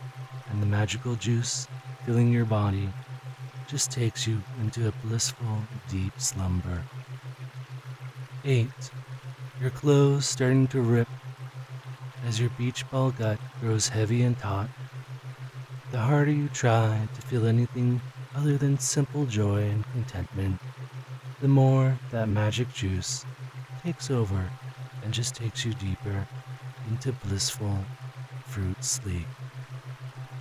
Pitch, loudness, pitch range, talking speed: 130 Hz, -28 LUFS, 115-130 Hz, 115 wpm